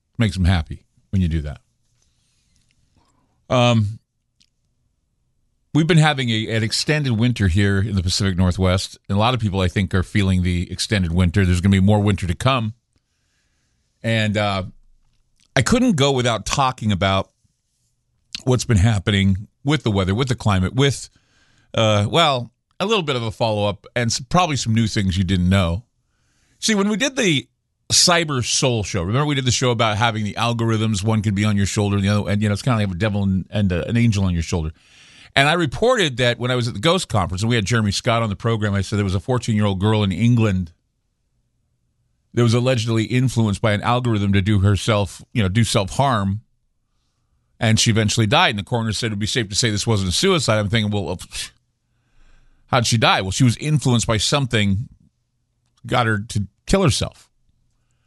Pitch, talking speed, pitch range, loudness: 110 Hz, 205 wpm, 100-120 Hz, -19 LUFS